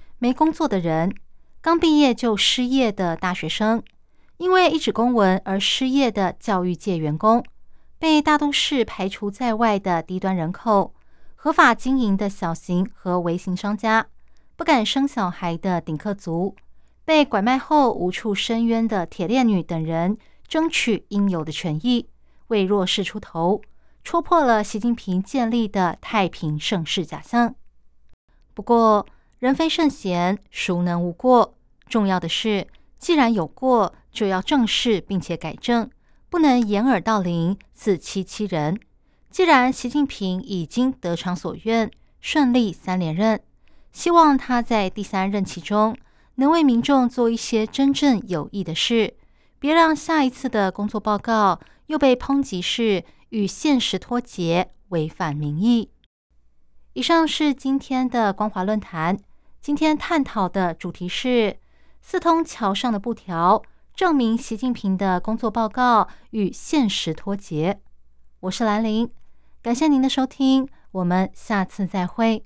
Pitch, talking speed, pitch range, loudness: 215 Hz, 215 characters per minute, 185-255 Hz, -21 LUFS